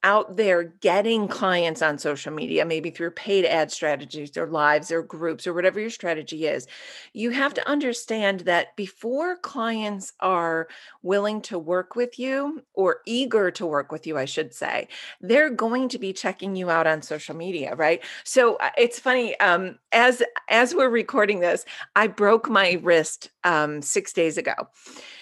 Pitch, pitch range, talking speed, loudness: 190 Hz, 165-225 Hz, 170 wpm, -23 LUFS